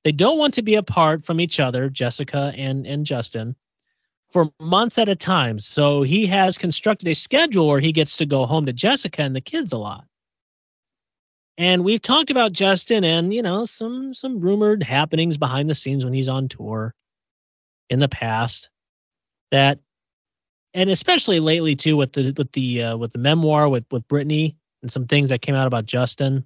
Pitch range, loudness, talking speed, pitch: 130-190 Hz, -19 LUFS, 190 wpm, 150 Hz